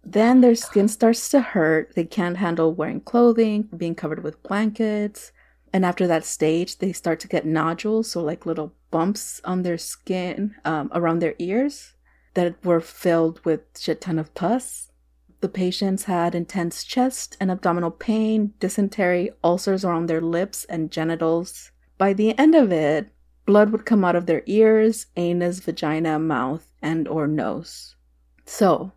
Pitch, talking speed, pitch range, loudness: 175 Hz, 160 wpm, 160-205 Hz, -22 LUFS